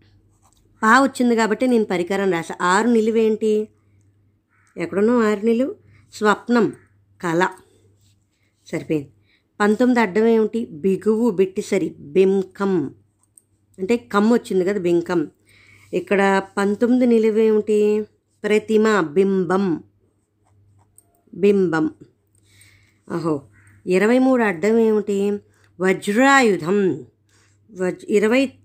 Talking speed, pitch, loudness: 80 wpm, 190 Hz, -19 LUFS